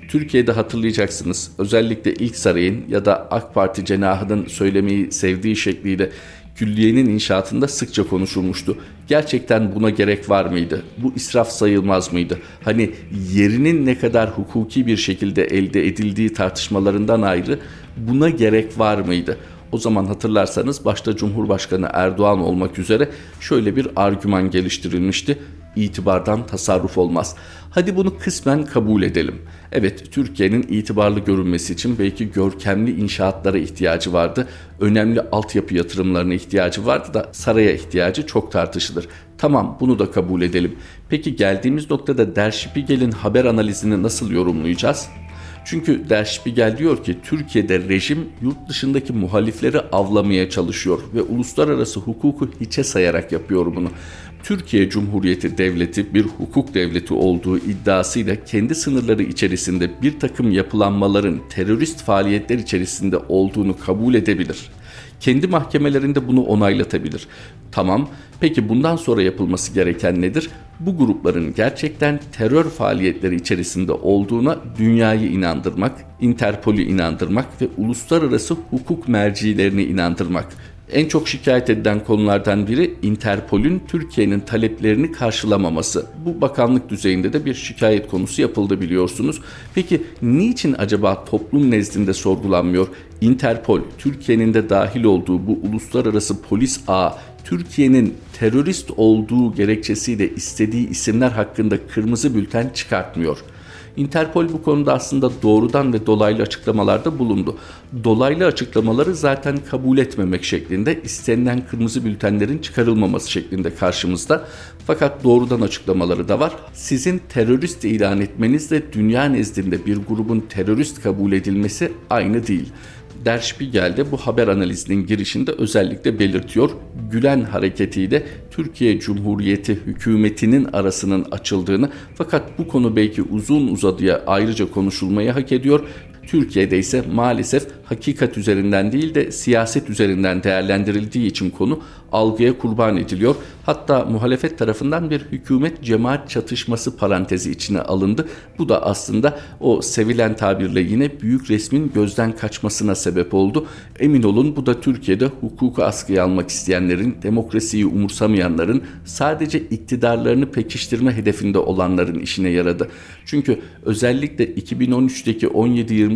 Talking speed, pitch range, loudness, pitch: 120 wpm, 95-125 Hz, -18 LUFS, 105 Hz